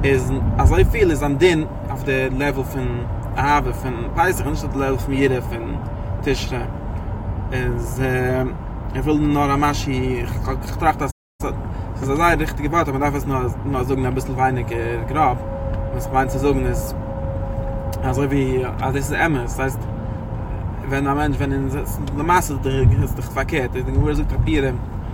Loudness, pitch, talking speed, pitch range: -21 LUFS, 130 Hz, 165 wpm, 110-135 Hz